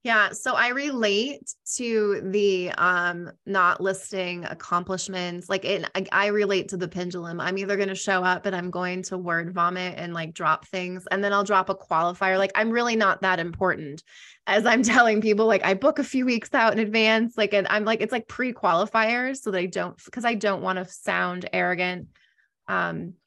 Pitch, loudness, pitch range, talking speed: 195 Hz, -24 LUFS, 180-220 Hz, 200 wpm